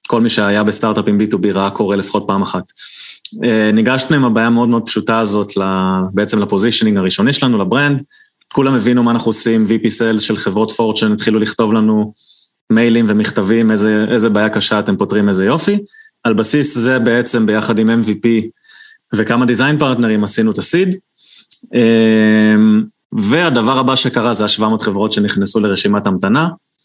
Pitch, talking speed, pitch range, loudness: 110 Hz, 155 wpm, 105-120 Hz, -13 LUFS